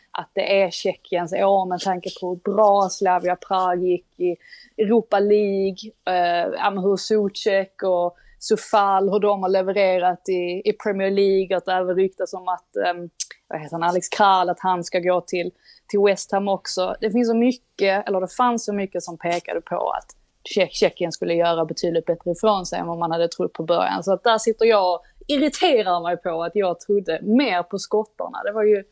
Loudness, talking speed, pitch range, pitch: -21 LUFS, 195 wpm, 180-205 Hz, 190 Hz